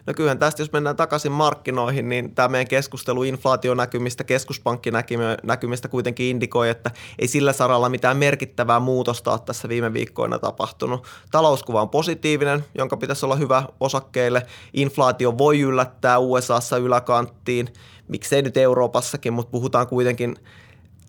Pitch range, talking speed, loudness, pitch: 120-135 Hz, 130 wpm, -21 LUFS, 125 Hz